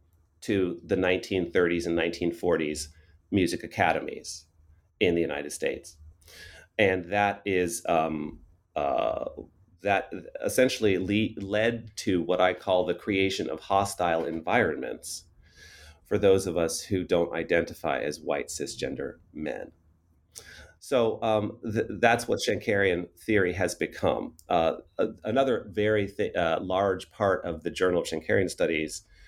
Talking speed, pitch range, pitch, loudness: 130 wpm, 80-100 Hz, 90 Hz, -27 LUFS